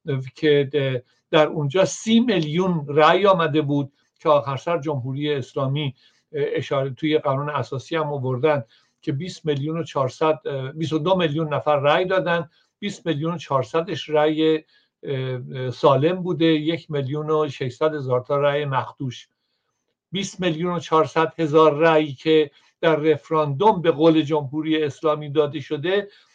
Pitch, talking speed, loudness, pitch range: 155 Hz, 135 wpm, -21 LUFS, 140-165 Hz